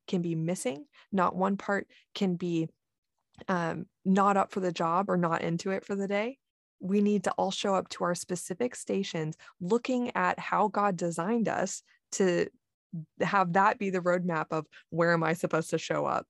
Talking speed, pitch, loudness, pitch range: 190 wpm, 185 Hz, -30 LUFS, 170-200 Hz